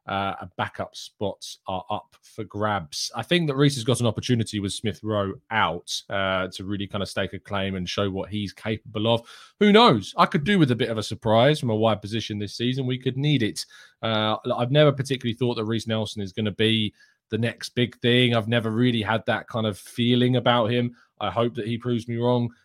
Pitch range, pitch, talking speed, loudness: 105-125 Hz, 115 Hz, 235 wpm, -24 LUFS